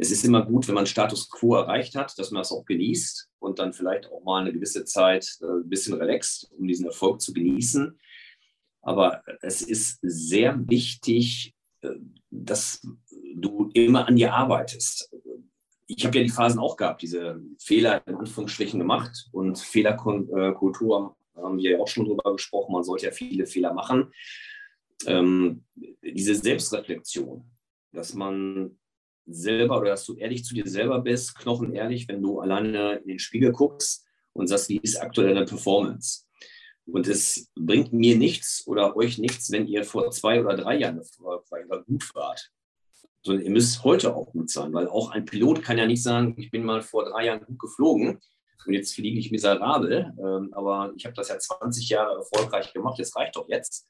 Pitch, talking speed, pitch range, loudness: 110 Hz, 175 wpm, 95-120 Hz, -25 LUFS